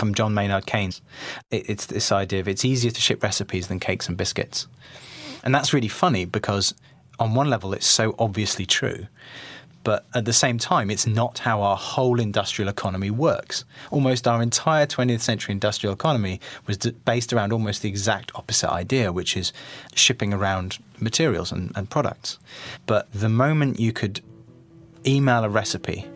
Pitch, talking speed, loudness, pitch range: 110 Hz, 170 wpm, -23 LUFS, 100-130 Hz